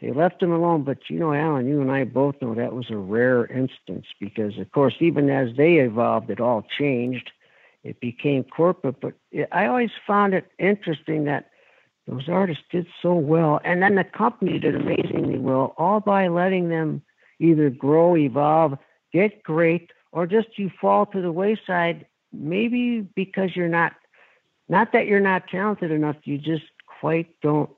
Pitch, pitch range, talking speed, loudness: 160 Hz, 140-185 Hz, 175 wpm, -22 LUFS